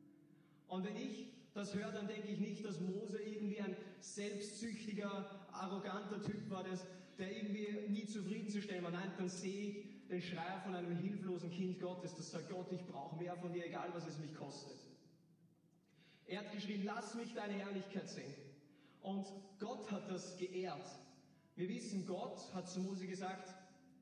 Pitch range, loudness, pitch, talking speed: 175-205 Hz, -46 LUFS, 190 Hz, 165 wpm